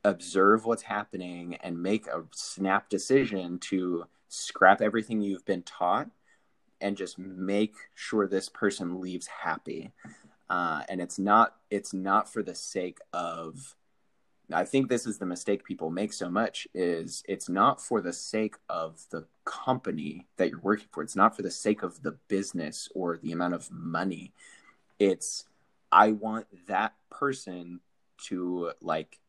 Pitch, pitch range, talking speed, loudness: 95 Hz, 90-110 Hz, 150 wpm, -29 LUFS